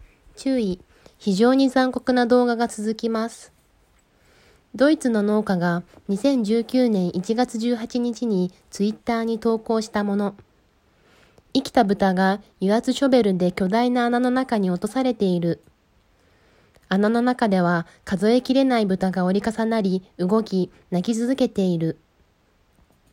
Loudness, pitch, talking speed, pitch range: -22 LUFS, 215 Hz, 235 characters per minute, 185-240 Hz